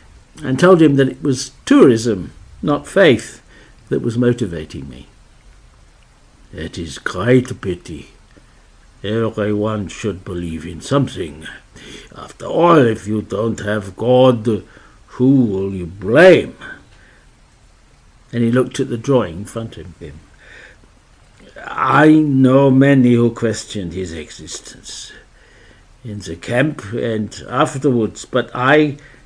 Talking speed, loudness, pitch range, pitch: 120 wpm, -15 LUFS, 100-130 Hz, 115 Hz